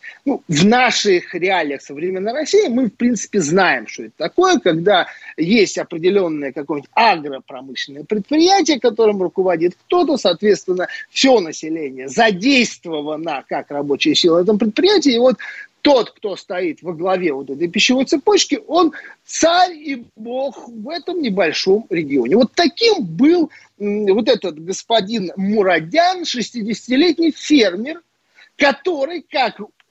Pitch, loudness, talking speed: 225 Hz, -16 LUFS, 125 wpm